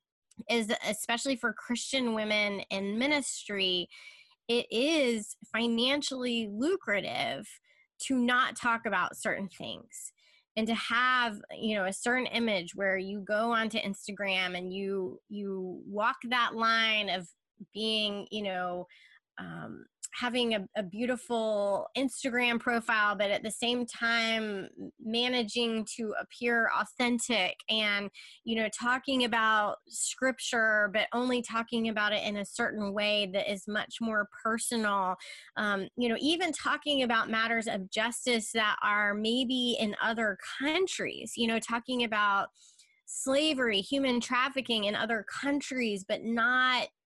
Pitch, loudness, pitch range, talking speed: 225 Hz, -30 LUFS, 210-250 Hz, 130 wpm